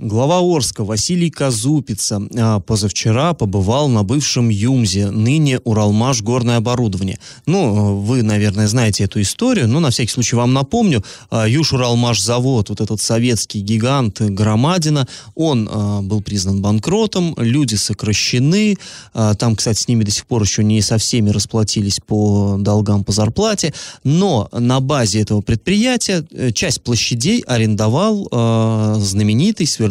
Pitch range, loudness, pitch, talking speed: 105-135 Hz, -16 LUFS, 115 Hz, 130 wpm